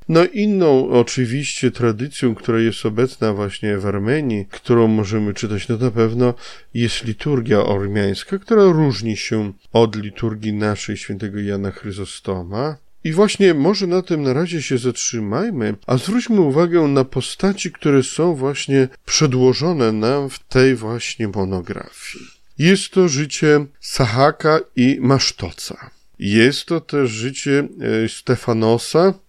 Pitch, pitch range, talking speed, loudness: 125 Hz, 110-150 Hz, 125 wpm, -18 LUFS